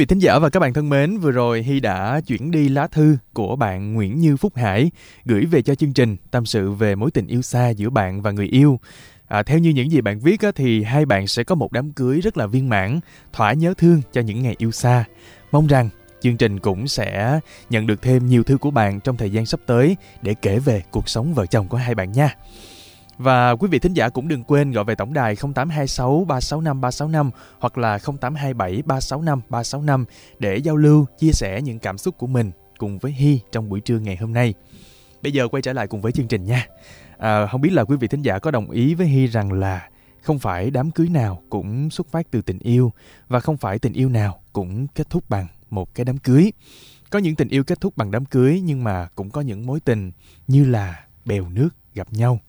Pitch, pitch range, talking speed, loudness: 125 Hz, 110-145 Hz, 235 wpm, -19 LUFS